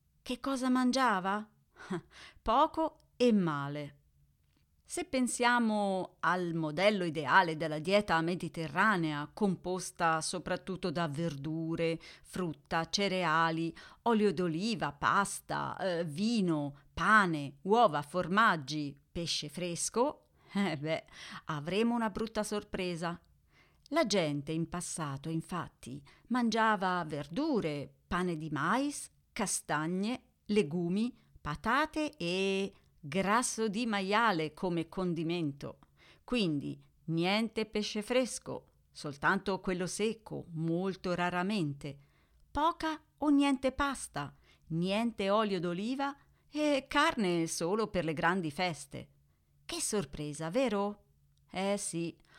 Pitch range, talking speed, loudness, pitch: 160-220 Hz, 95 wpm, -33 LUFS, 180 Hz